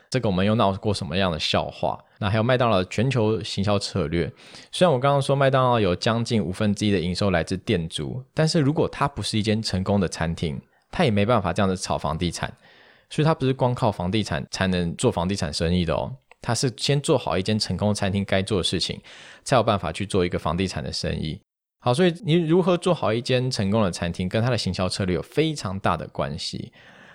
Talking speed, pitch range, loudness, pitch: 340 characters per minute, 90-125 Hz, -23 LUFS, 105 Hz